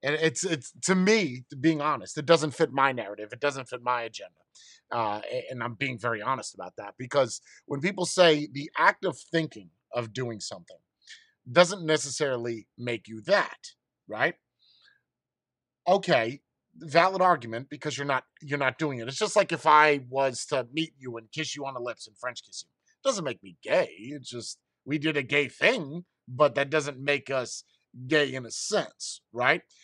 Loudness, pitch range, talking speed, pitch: -27 LUFS, 125-160 Hz, 185 wpm, 145 Hz